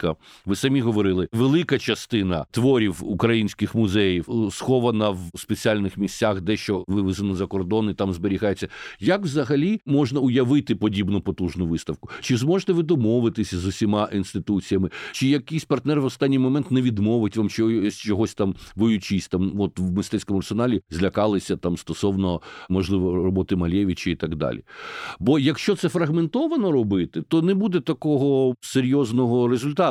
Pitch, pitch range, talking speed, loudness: 105 Hz, 95-135 Hz, 140 wpm, -23 LUFS